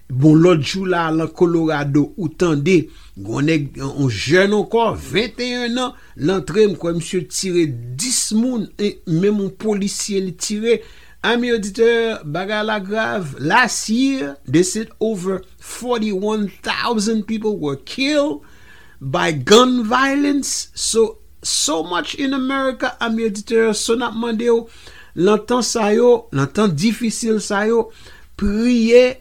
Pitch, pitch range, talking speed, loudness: 215 Hz, 175-235 Hz, 135 wpm, -18 LUFS